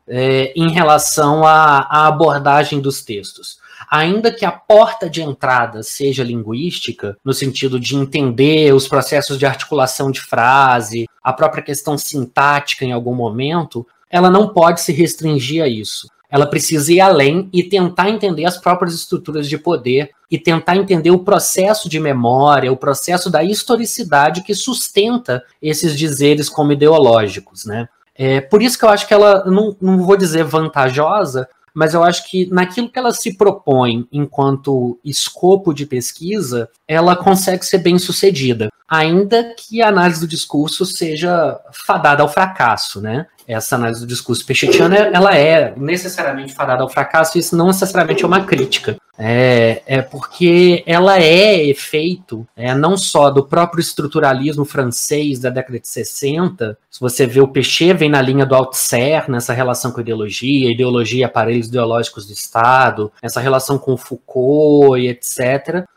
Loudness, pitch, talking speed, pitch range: -14 LUFS, 150 Hz, 160 wpm, 130-180 Hz